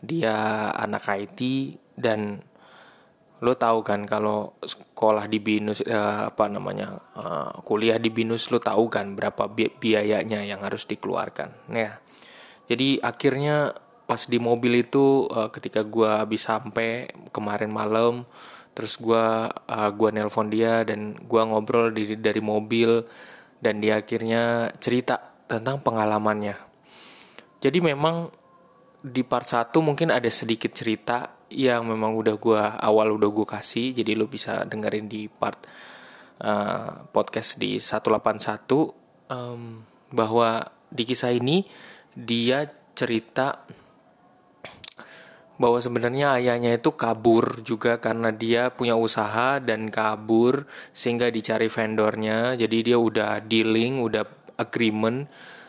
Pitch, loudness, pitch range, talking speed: 115 Hz, -24 LUFS, 110-120 Hz, 125 wpm